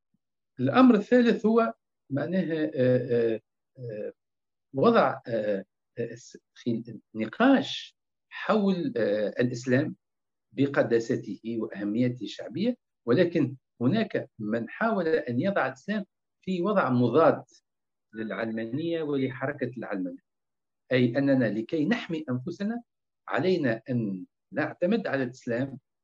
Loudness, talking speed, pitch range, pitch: -27 LUFS, 80 wpm, 120-190 Hz, 140 Hz